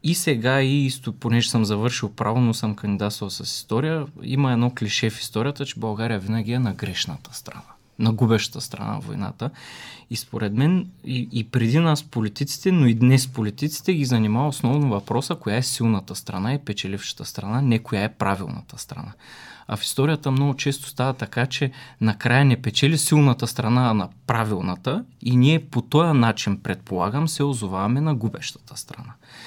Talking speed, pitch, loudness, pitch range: 175 wpm, 120 Hz, -22 LUFS, 110-140 Hz